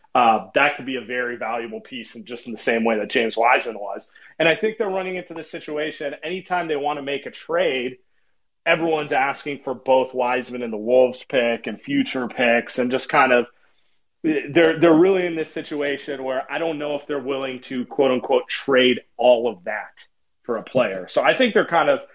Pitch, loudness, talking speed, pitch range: 140 Hz, -21 LUFS, 210 wpm, 125-165 Hz